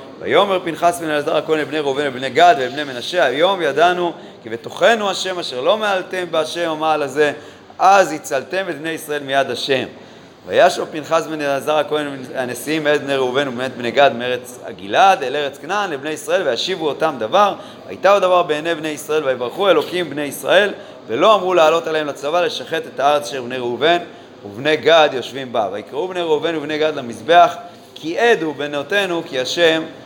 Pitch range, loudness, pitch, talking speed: 140-175 Hz, -17 LUFS, 155 Hz, 160 wpm